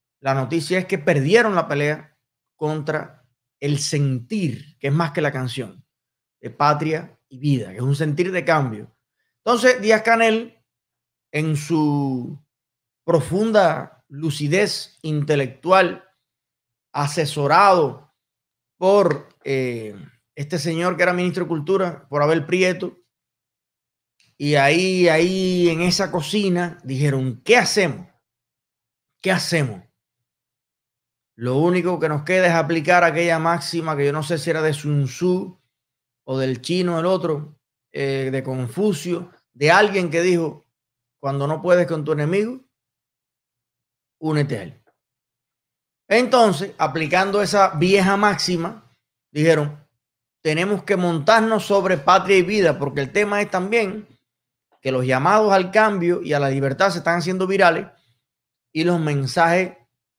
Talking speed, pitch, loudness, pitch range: 130 wpm, 160 Hz, -19 LUFS, 135-180 Hz